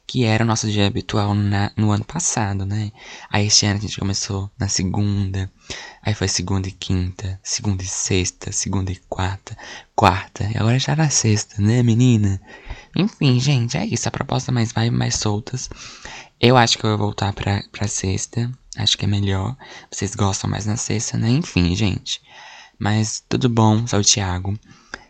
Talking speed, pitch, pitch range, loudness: 180 wpm, 105 Hz, 100-120 Hz, -20 LUFS